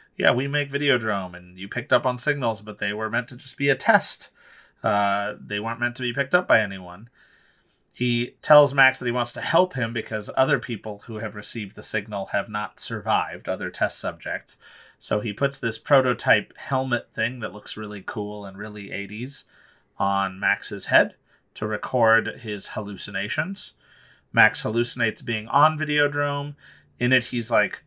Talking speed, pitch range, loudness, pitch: 175 wpm, 105-130 Hz, -24 LUFS, 115 Hz